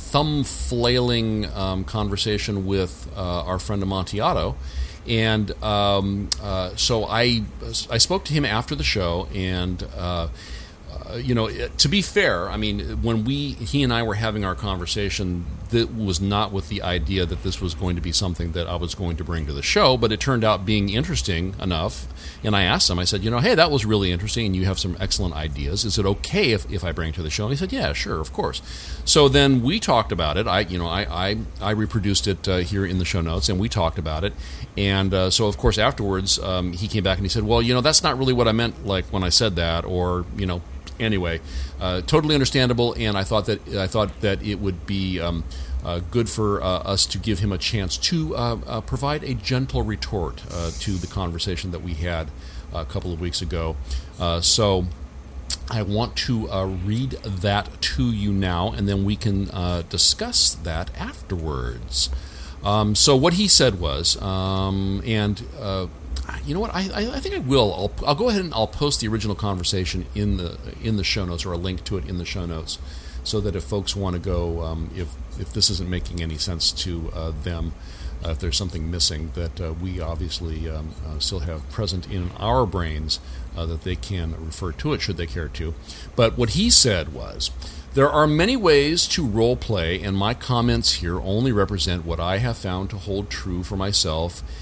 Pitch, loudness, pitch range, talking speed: 95 Hz, -22 LUFS, 85-110 Hz, 215 wpm